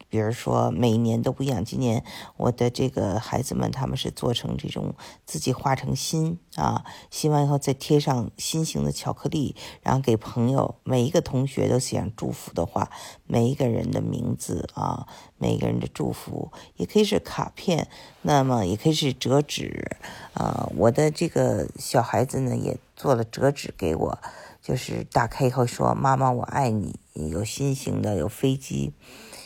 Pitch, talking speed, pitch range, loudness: 130 Hz, 255 characters per minute, 110-140 Hz, -25 LUFS